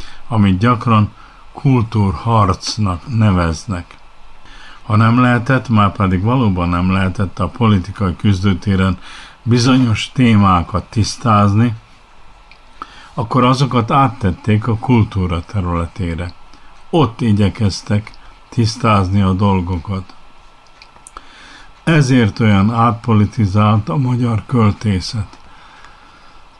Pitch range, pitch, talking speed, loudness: 95-120 Hz, 105 Hz, 80 wpm, -15 LUFS